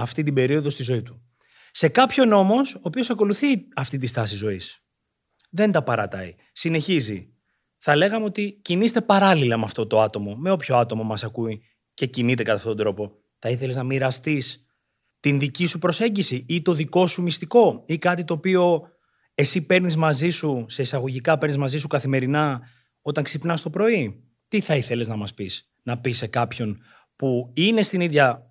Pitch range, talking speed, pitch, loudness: 120-175 Hz, 180 wpm, 145 Hz, -22 LUFS